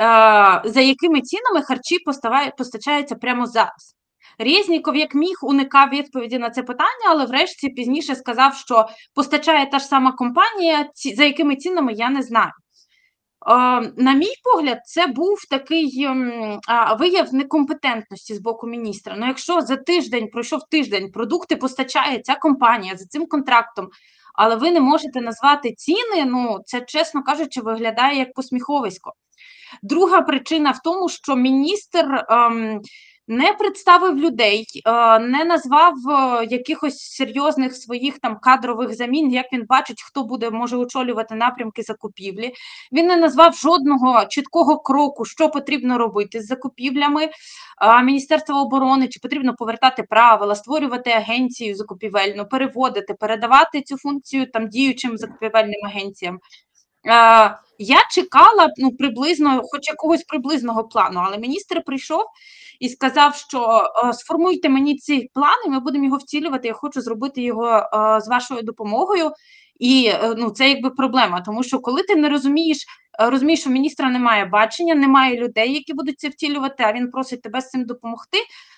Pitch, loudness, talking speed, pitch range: 265 Hz, -17 LUFS, 145 wpm, 235-300 Hz